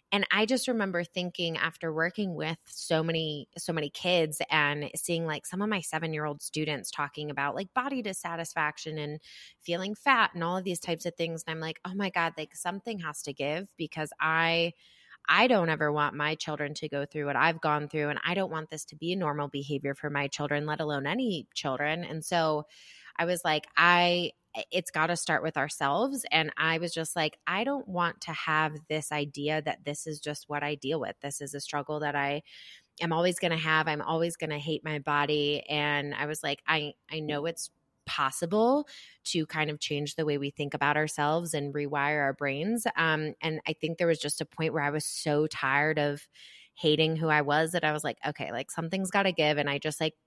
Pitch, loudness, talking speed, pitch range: 155 Hz, -30 LUFS, 220 wpm, 150-170 Hz